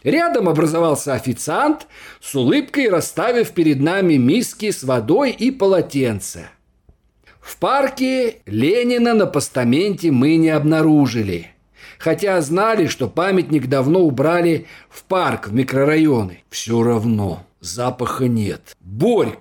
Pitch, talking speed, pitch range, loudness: 155 Hz, 110 wpm, 125-195 Hz, -17 LUFS